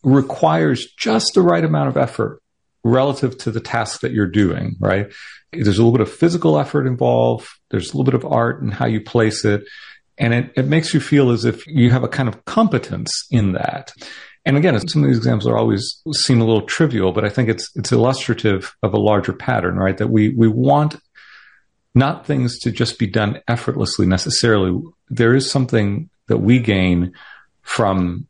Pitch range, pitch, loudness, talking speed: 105-135 Hz, 115 Hz, -17 LUFS, 195 wpm